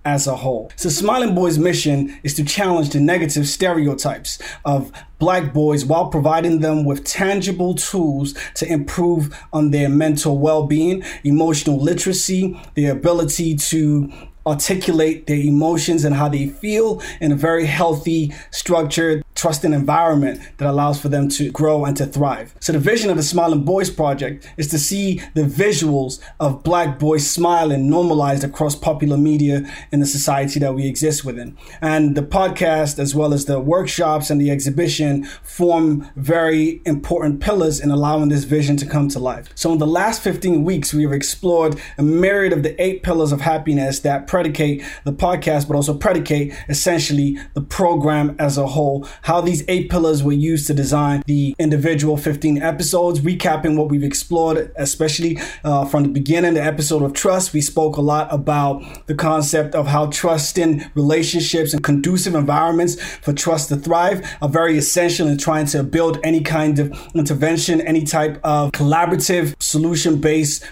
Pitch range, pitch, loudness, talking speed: 145-165 Hz, 155 Hz, -18 LUFS, 170 wpm